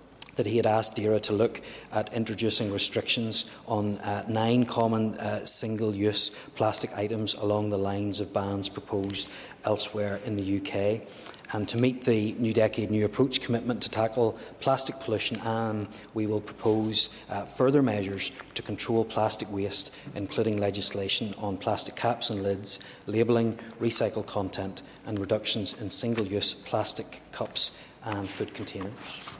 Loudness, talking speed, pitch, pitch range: -27 LUFS, 145 wpm, 110 Hz, 100-115 Hz